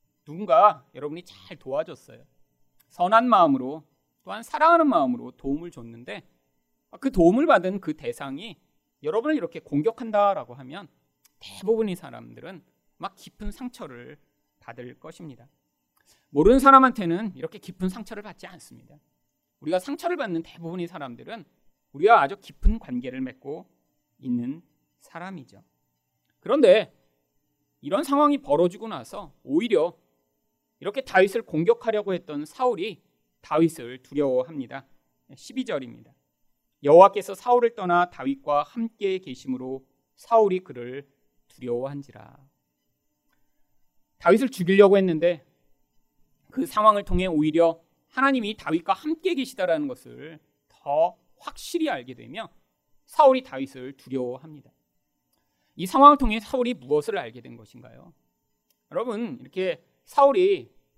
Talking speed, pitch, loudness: 290 characters per minute, 170 Hz, -23 LUFS